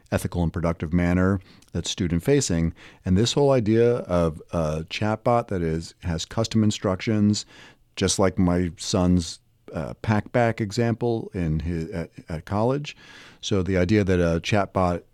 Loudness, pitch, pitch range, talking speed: -24 LUFS, 95 Hz, 85-110 Hz, 145 wpm